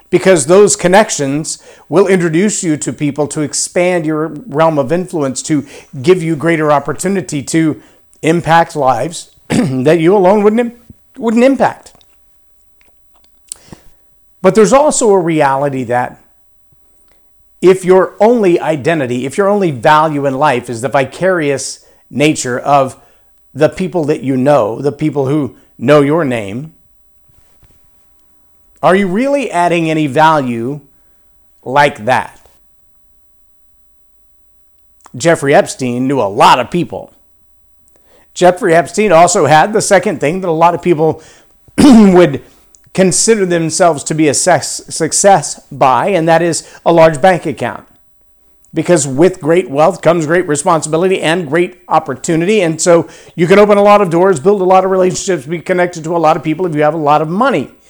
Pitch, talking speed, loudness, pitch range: 160 Hz, 145 wpm, -11 LUFS, 140-180 Hz